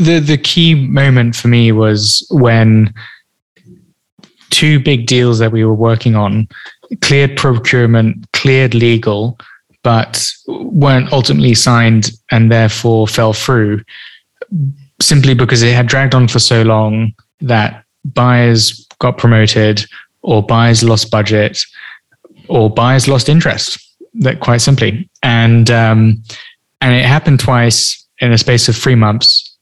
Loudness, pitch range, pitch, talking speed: -10 LUFS, 110-135 Hz, 120 Hz, 130 wpm